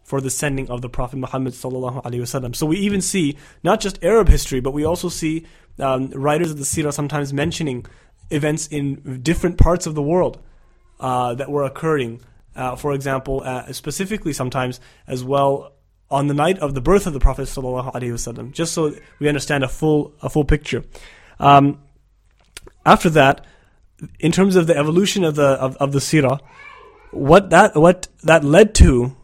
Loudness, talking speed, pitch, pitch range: -18 LUFS, 185 wpm, 140 Hz, 130-160 Hz